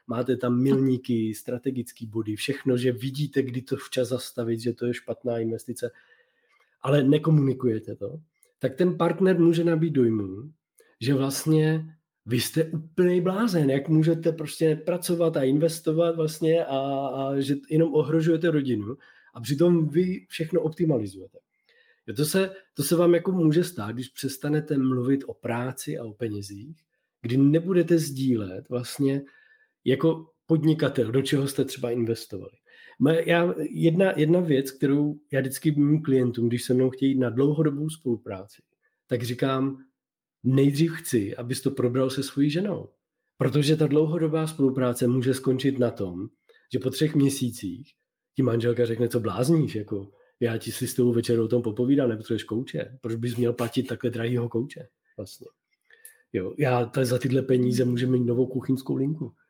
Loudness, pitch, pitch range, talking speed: -25 LUFS, 135 Hz, 125-160 Hz, 150 wpm